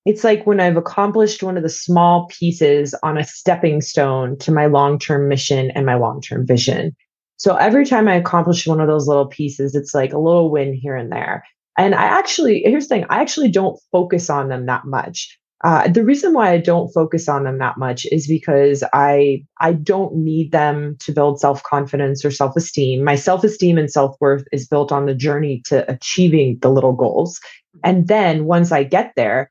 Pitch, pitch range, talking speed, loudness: 150 Hz, 140-175 Hz, 210 wpm, -16 LUFS